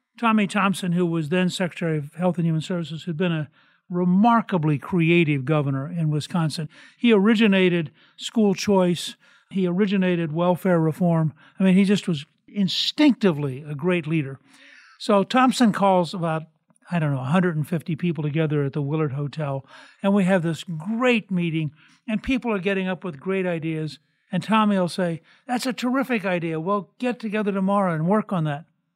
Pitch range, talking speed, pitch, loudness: 160-205 Hz, 165 wpm, 180 Hz, -23 LUFS